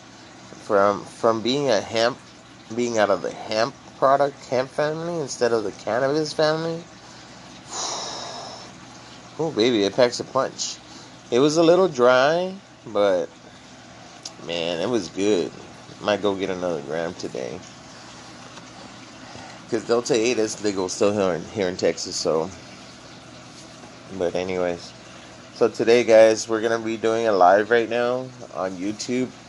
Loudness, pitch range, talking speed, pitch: -22 LUFS, 95-125 Hz, 140 wpm, 110 Hz